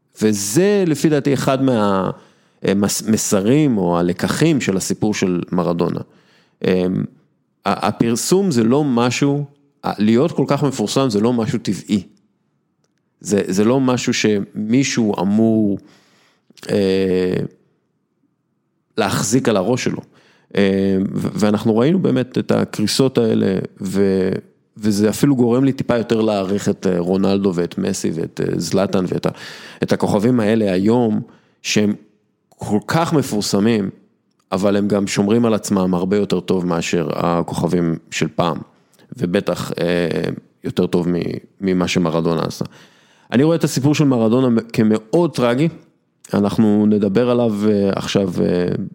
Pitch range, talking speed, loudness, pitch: 95-125 Hz, 120 wpm, -18 LUFS, 105 Hz